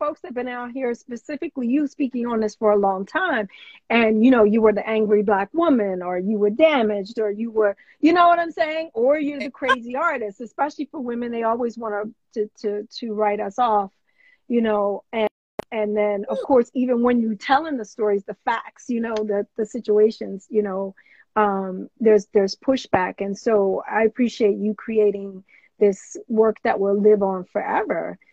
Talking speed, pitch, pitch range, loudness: 195 wpm, 220 Hz, 205-250 Hz, -21 LUFS